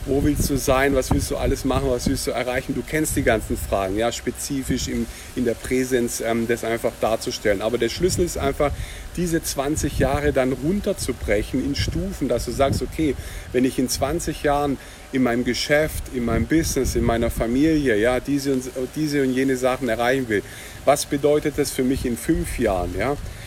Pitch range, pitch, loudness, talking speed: 120-145 Hz, 130 Hz, -22 LUFS, 195 wpm